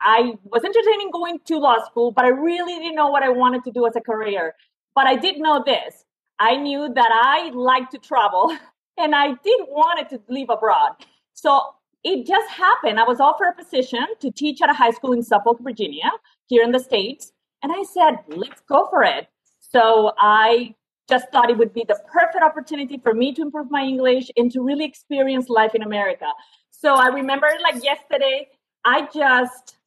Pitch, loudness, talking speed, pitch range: 275 Hz, -19 LUFS, 205 wpm, 240-315 Hz